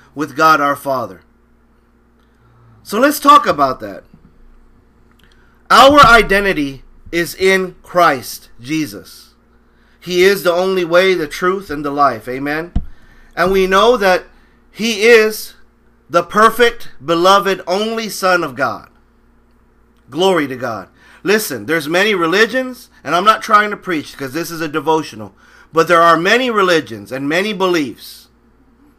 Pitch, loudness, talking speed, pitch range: 170 Hz, -13 LUFS, 135 wpm, 140-195 Hz